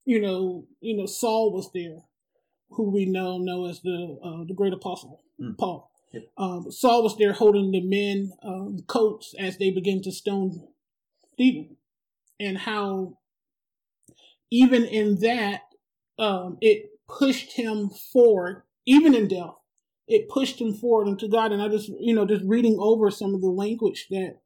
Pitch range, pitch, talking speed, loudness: 190-230 Hz, 205 Hz, 160 wpm, -24 LUFS